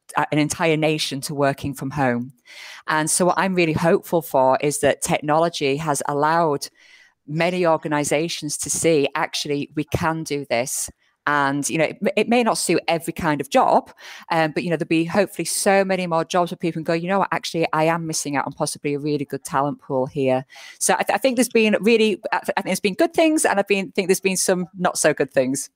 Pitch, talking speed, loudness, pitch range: 160 Hz, 230 wpm, -21 LUFS, 145-180 Hz